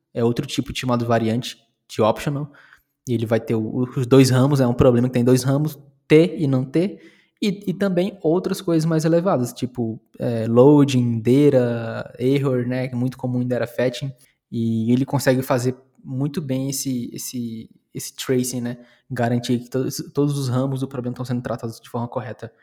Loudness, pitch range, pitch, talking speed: -21 LUFS, 120-140 Hz, 130 Hz, 195 wpm